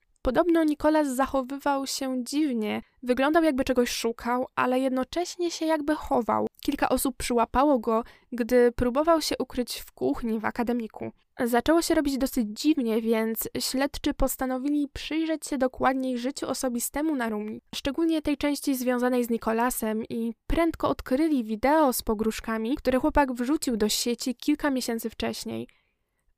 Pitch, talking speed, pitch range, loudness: 260 Hz, 140 wpm, 235-290 Hz, -26 LUFS